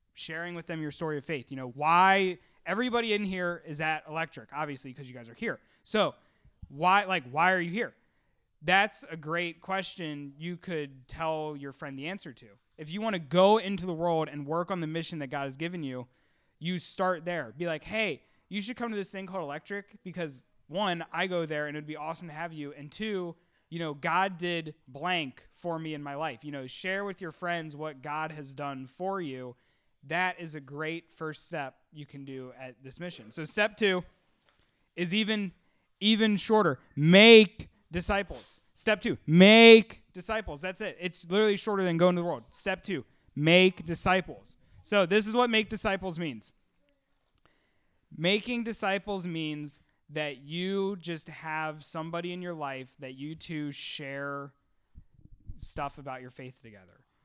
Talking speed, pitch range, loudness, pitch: 185 wpm, 145-190 Hz, -28 LUFS, 165 Hz